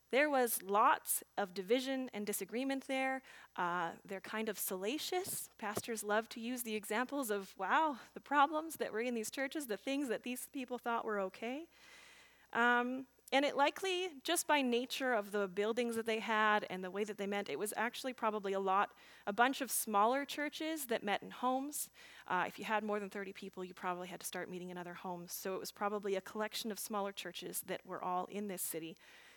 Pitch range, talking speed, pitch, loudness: 200-260 Hz, 210 wpm, 220 Hz, -38 LUFS